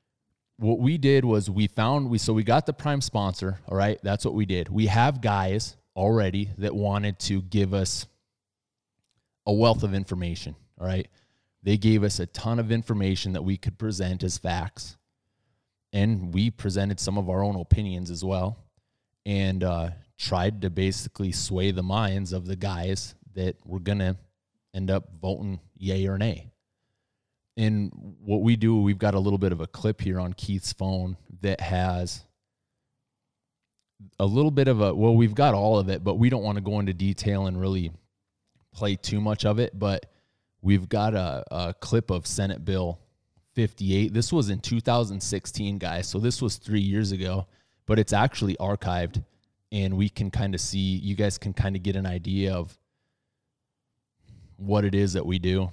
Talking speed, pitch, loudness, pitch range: 180 wpm, 100 Hz, -26 LUFS, 95-110 Hz